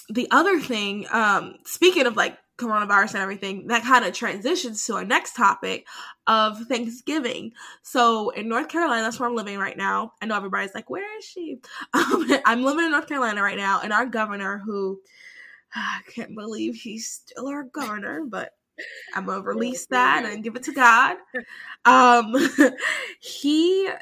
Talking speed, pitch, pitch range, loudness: 170 wpm, 240 Hz, 215-290 Hz, -22 LUFS